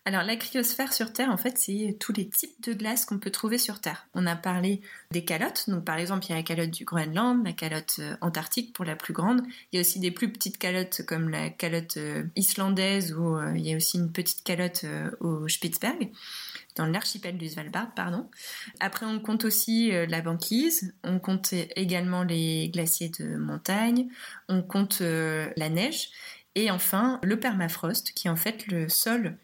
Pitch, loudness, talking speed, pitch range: 185 Hz, -28 LUFS, 205 wpm, 170-225 Hz